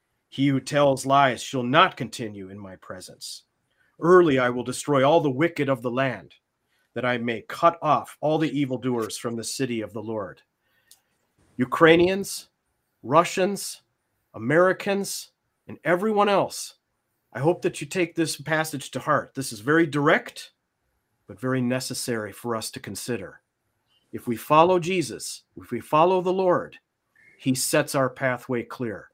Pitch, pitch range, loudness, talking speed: 135 Hz, 120-165 Hz, -23 LUFS, 150 wpm